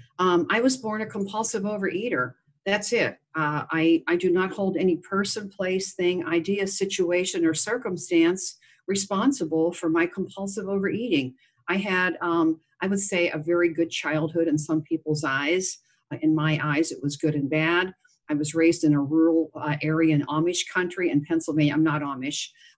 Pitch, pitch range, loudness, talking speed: 170 Hz, 155-185 Hz, -25 LUFS, 175 wpm